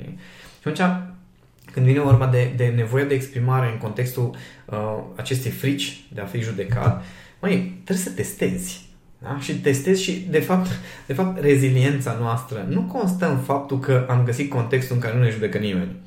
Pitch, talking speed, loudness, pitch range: 130 Hz, 175 wpm, -22 LUFS, 120-145 Hz